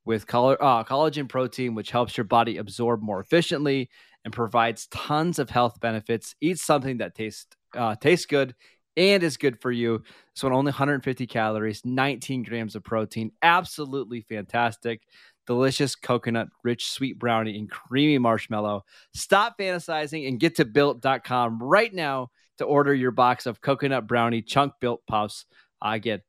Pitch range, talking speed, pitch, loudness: 115-140 Hz, 155 wpm, 125 Hz, -25 LUFS